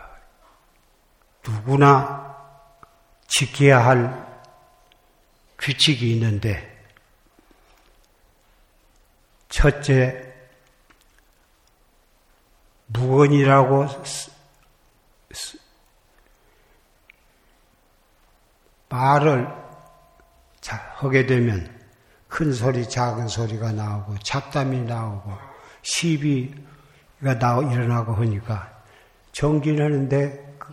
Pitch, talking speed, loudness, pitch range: 130 Hz, 115 characters per minute, -21 LUFS, 115-140 Hz